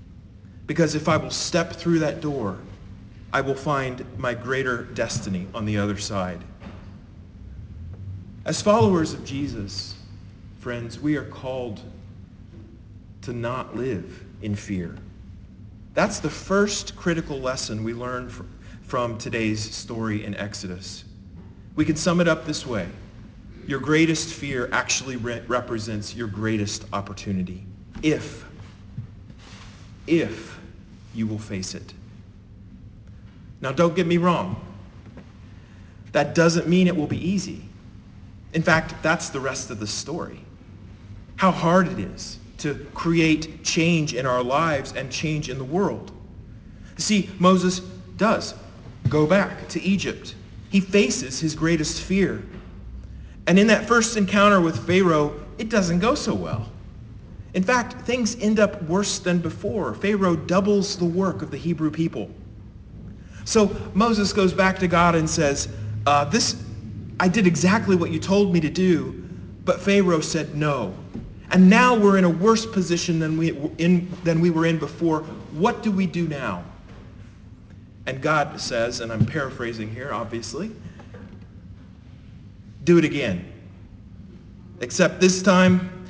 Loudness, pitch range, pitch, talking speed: -22 LUFS, 100-170 Hz, 125 Hz, 140 wpm